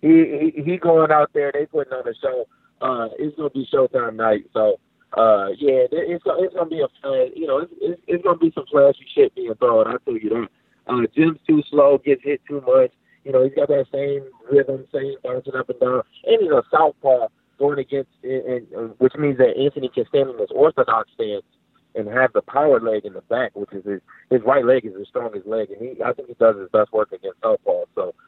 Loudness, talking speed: -20 LUFS, 250 wpm